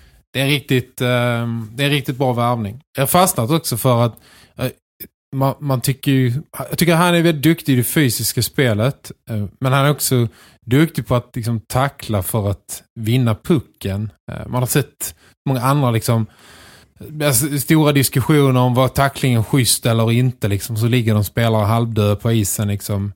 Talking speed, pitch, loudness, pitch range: 160 wpm, 125 Hz, -17 LUFS, 110-140 Hz